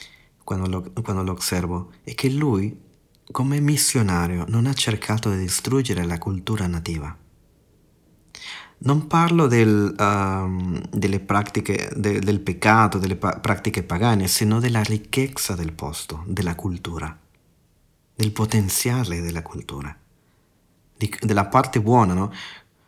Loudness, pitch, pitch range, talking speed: -22 LUFS, 100 Hz, 90-115 Hz, 120 wpm